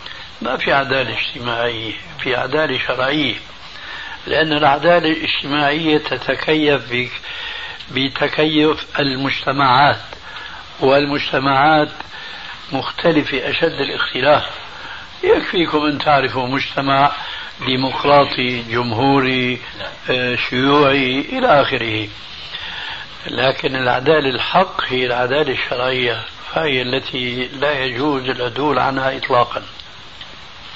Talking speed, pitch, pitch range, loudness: 75 wpm, 135 Hz, 125-145 Hz, -17 LUFS